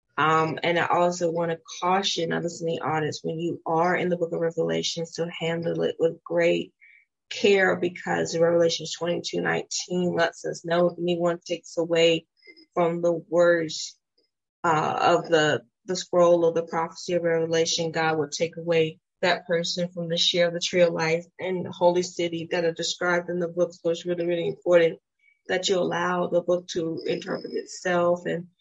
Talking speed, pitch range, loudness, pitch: 180 wpm, 165-175 Hz, -25 LUFS, 170 Hz